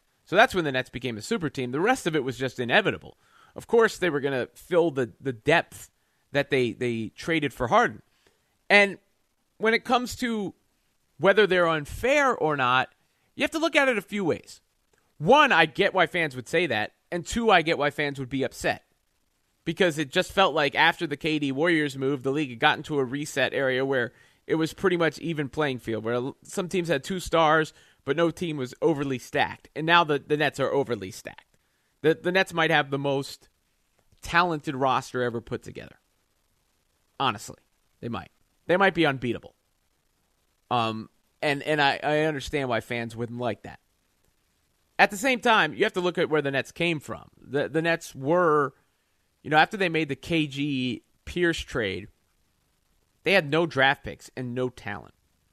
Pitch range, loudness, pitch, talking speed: 130-170 Hz, -25 LUFS, 150 Hz, 195 wpm